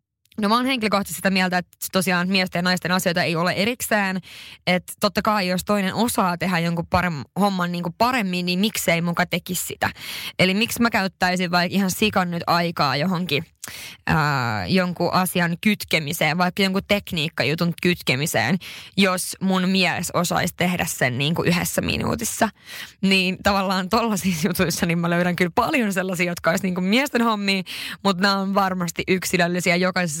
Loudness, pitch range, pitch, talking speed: -21 LUFS, 175-195 Hz, 185 Hz, 165 wpm